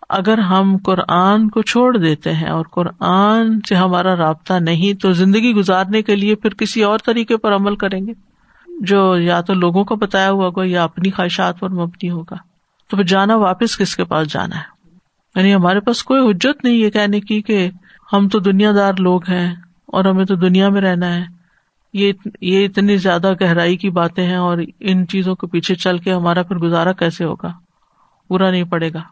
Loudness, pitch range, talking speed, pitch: -15 LUFS, 180-205 Hz, 195 wpm, 190 Hz